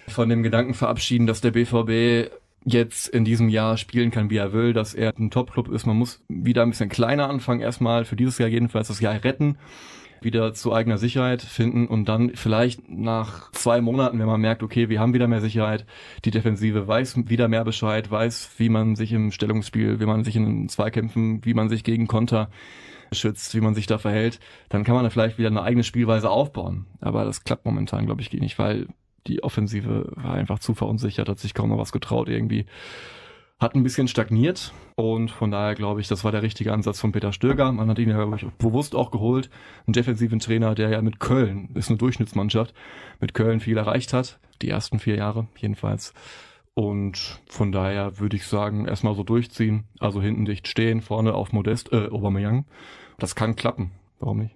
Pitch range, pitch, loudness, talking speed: 110-120 Hz, 115 Hz, -23 LUFS, 200 wpm